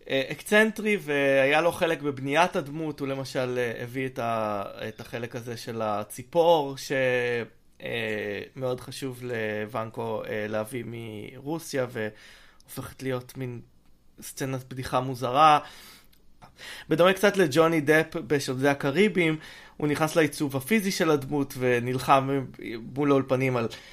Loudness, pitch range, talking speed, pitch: -26 LUFS, 120-155 Hz, 110 wpm, 135 Hz